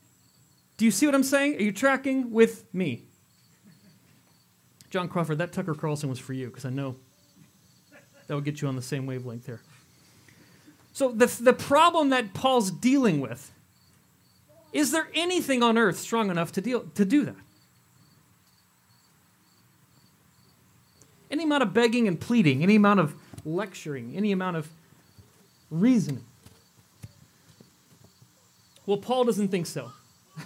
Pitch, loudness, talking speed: 190 Hz, -25 LUFS, 140 wpm